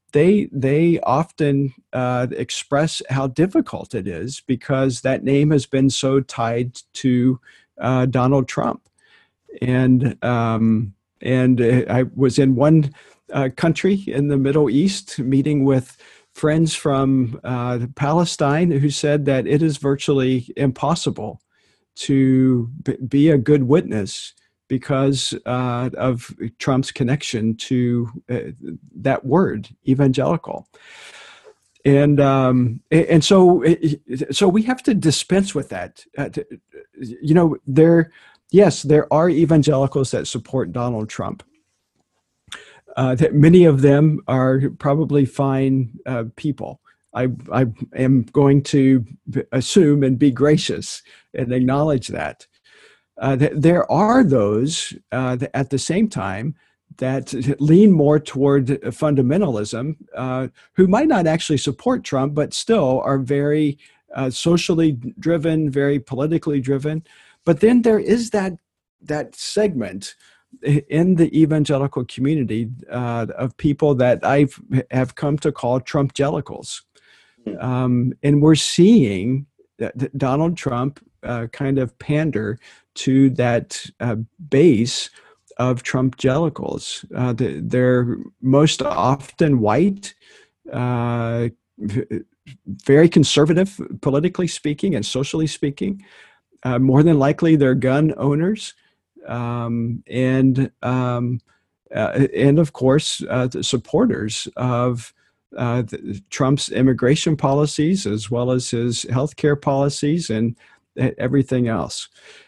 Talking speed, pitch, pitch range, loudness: 120 wpm, 135 Hz, 125-155 Hz, -18 LUFS